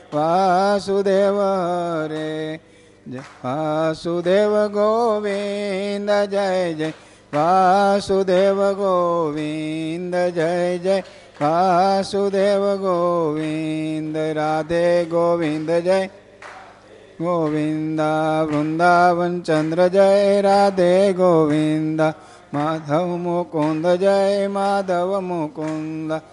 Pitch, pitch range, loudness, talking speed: 175 Hz, 155-195 Hz, -19 LUFS, 55 wpm